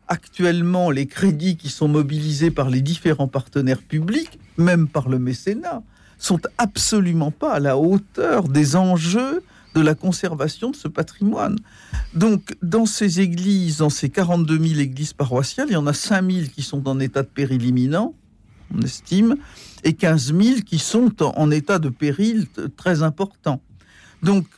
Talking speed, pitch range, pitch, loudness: 160 wpm, 145-195 Hz, 165 Hz, -20 LUFS